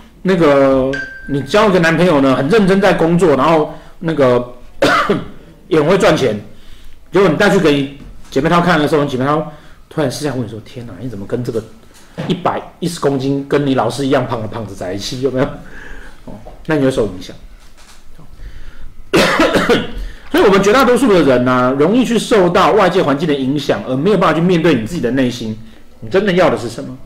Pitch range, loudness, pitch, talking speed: 125-170 Hz, -13 LUFS, 140 Hz, 295 characters per minute